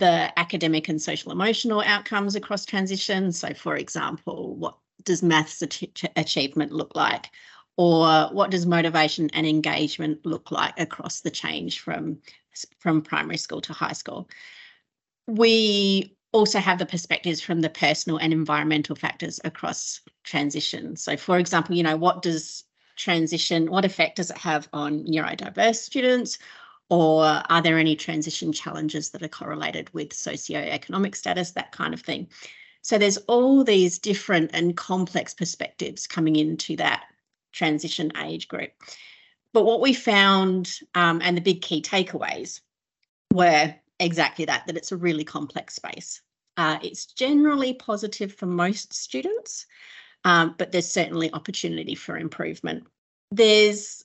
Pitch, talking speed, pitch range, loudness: 175 Hz, 140 wpm, 160-200 Hz, -23 LUFS